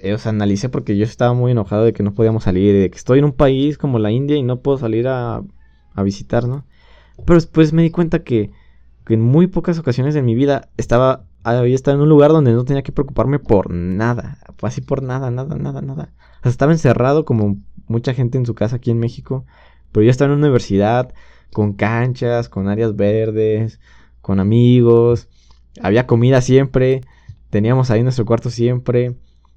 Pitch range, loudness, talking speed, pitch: 105-135 Hz, -16 LUFS, 195 wpm, 120 Hz